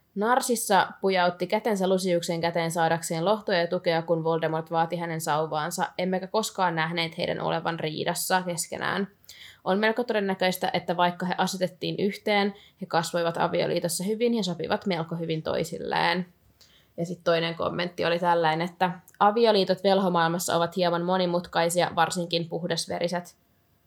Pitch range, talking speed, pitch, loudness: 165-185 Hz, 130 wpm, 175 Hz, -26 LUFS